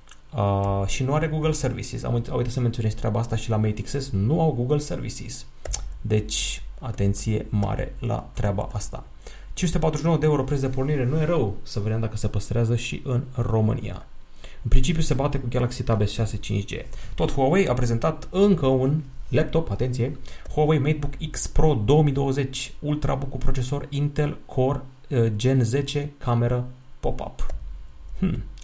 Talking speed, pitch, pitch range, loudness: 155 wpm, 130 Hz, 110-145 Hz, -25 LUFS